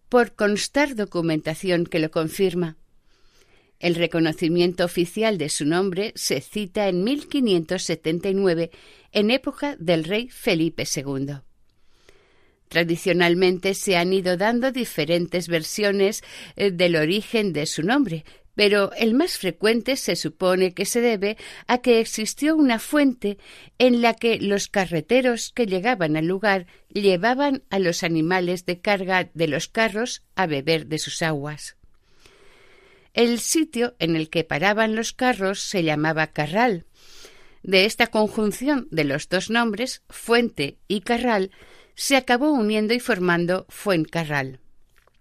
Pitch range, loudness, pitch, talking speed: 170-235 Hz, -22 LUFS, 195 Hz, 130 wpm